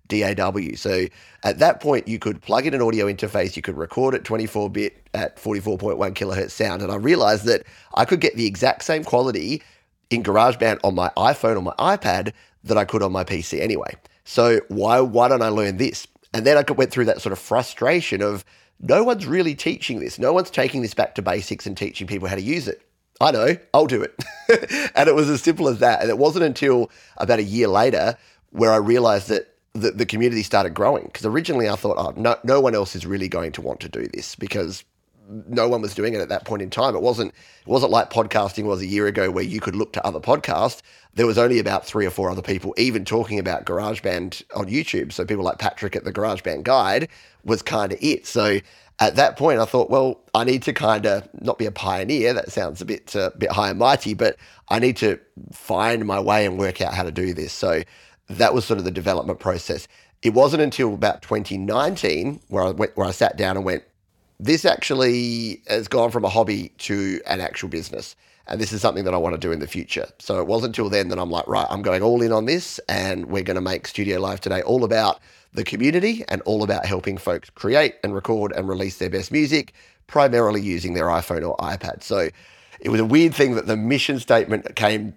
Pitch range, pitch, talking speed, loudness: 100-120 Hz, 110 Hz, 230 wpm, -21 LUFS